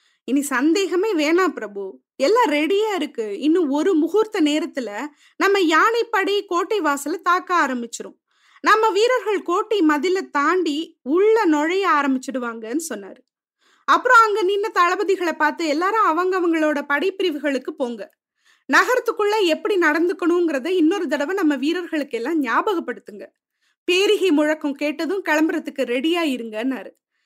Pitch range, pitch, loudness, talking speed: 295-385 Hz, 330 Hz, -19 LUFS, 110 wpm